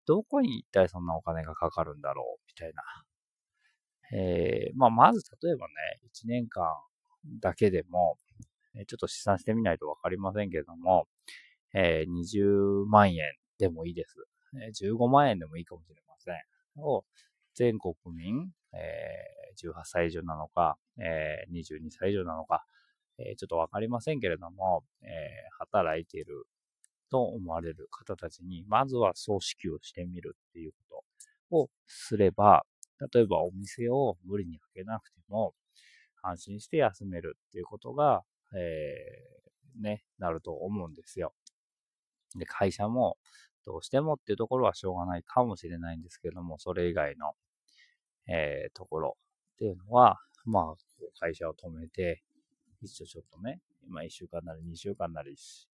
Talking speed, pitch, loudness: 290 characters per minute, 100 Hz, -30 LUFS